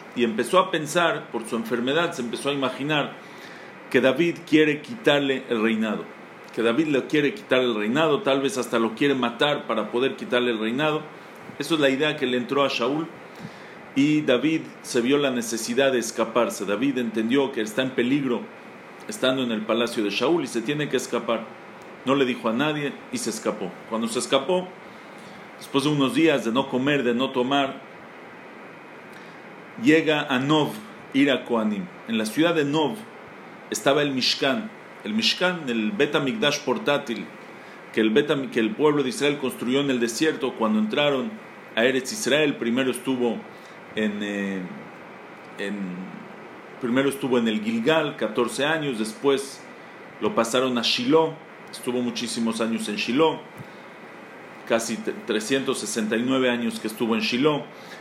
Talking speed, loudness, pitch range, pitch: 160 wpm, -24 LUFS, 115-145 Hz, 130 Hz